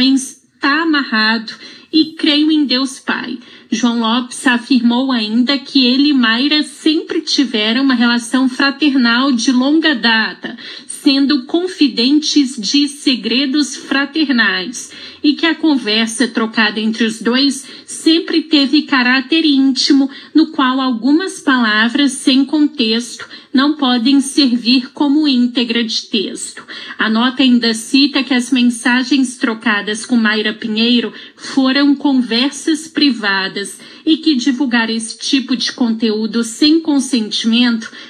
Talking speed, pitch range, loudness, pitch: 120 wpm, 235-290 Hz, -13 LUFS, 265 Hz